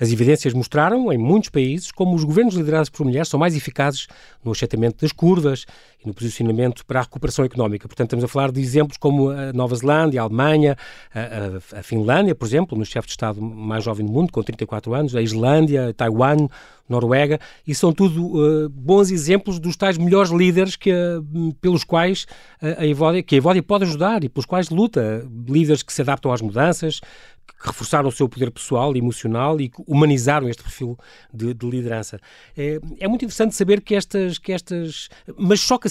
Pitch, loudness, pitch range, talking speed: 145 Hz, -19 LUFS, 120-170 Hz, 190 wpm